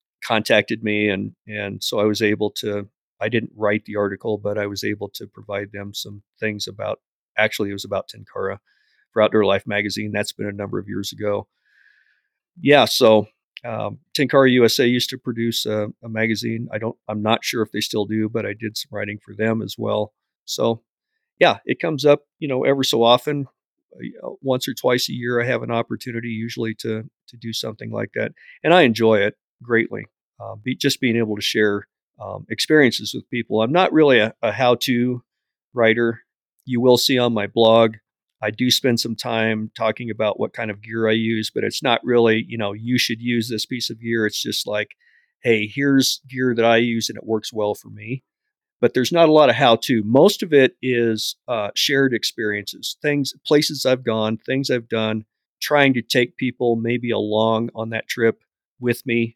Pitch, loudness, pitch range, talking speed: 115 Hz, -20 LUFS, 105-125 Hz, 200 wpm